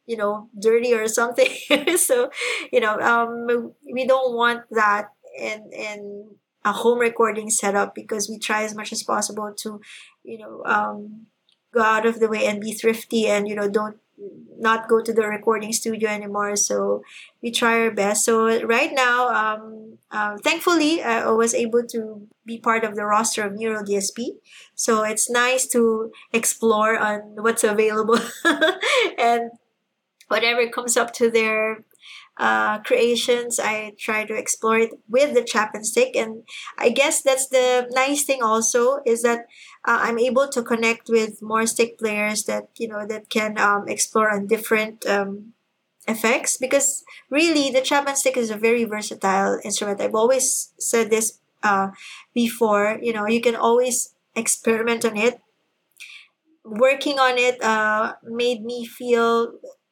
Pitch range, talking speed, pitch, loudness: 215-245 Hz, 160 wpm, 230 Hz, -21 LUFS